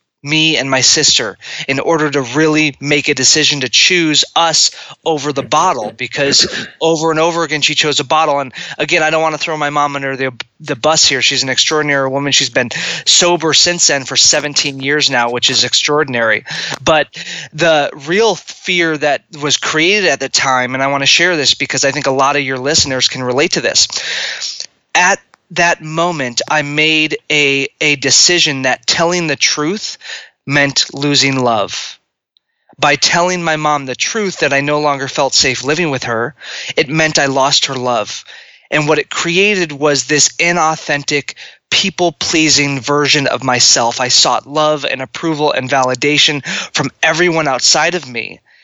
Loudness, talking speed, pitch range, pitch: -12 LUFS, 180 wpm, 135-160 Hz, 145 Hz